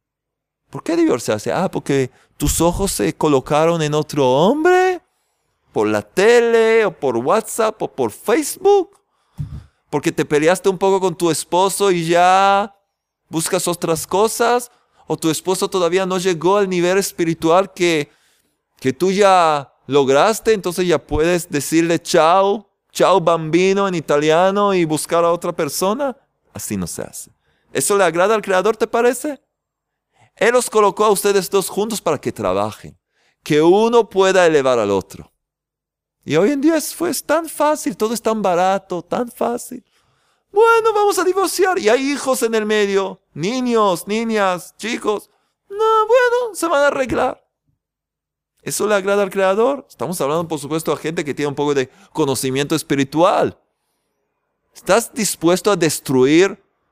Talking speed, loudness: 150 wpm, -17 LUFS